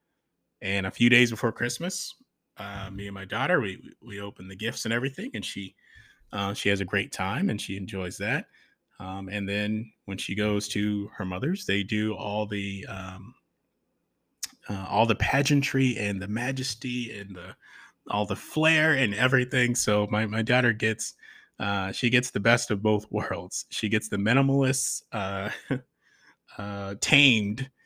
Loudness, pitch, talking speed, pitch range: -26 LUFS, 105 Hz, 170 wpm, 100-125 Hz